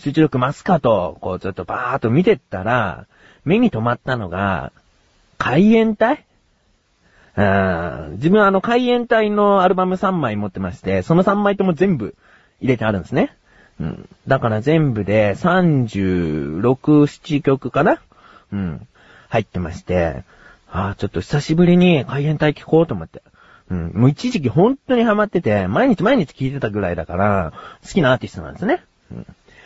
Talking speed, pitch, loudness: 310 characters per minute, 135 Hz, -18 LUFS